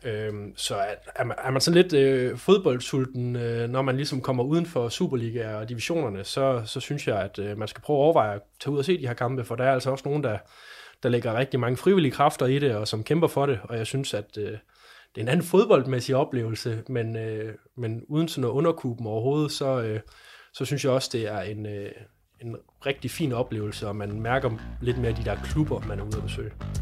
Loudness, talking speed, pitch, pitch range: -26 LUFS, 235 wpm, 125 Hz, 110-140 Hz